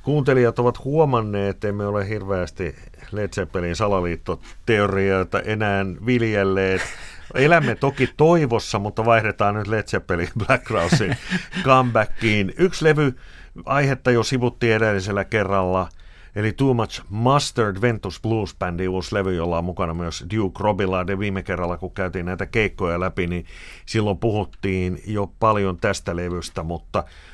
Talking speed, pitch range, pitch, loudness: 130 wpm, 95-115 Hz, 100 Hz, -21 LUFS